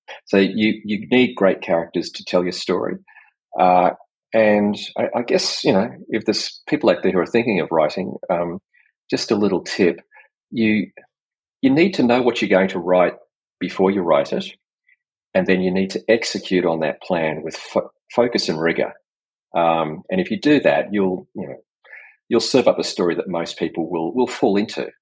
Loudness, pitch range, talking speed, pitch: -19 LUFS, 90-110 Hz, 195 wpm, 95 Hz